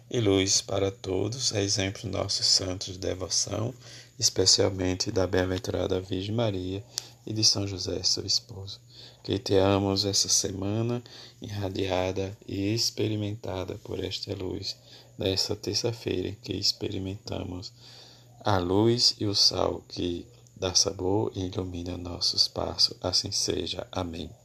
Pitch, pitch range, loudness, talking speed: 100 Hz, 95-115 Hz, -27 LUFS, 125 wpm